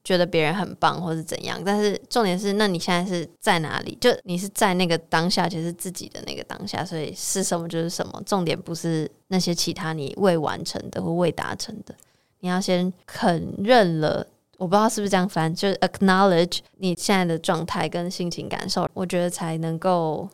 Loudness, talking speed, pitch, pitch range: -24 LUFS, 335 characters per minute, 180 Hz, 165-190 Hz